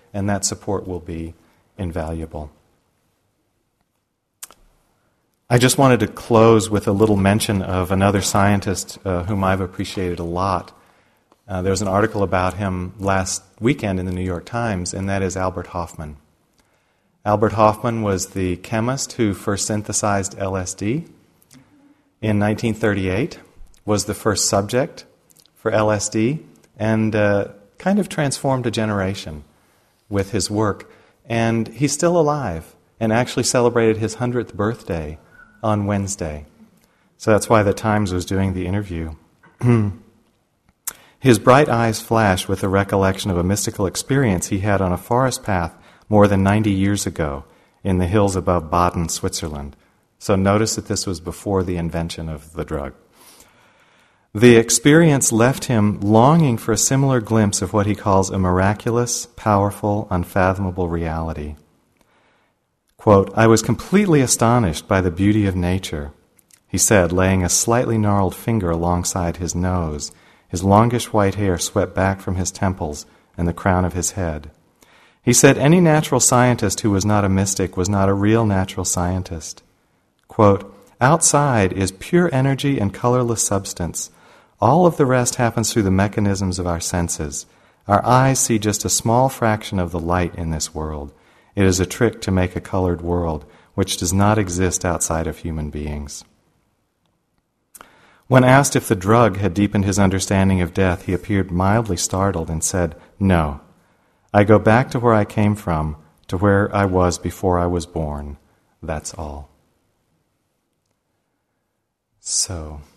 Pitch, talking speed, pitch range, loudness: 100 Hz, 150 wpm, 90-110 Hz, -18 LUFS